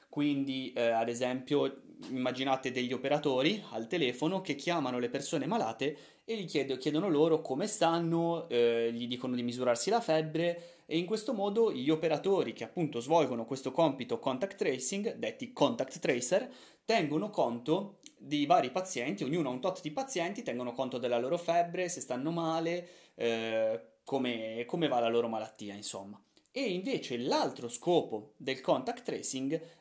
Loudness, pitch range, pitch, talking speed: -33 LUFS, 120-170 Hz, 145 Hz, 160 wpm